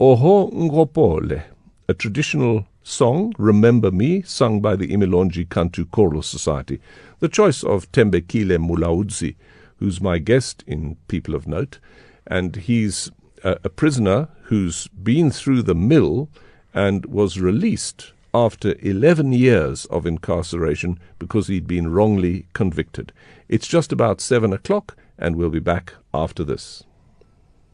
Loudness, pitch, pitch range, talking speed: -19 LUFS, 100 Hz, 90-125 Hz, 130 wpm